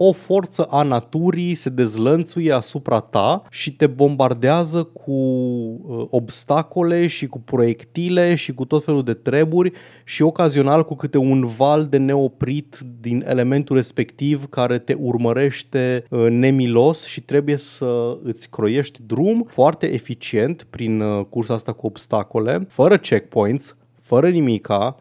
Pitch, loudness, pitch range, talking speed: 135 Hz, -19 LUFS, 120-155 Hz, 130 wpm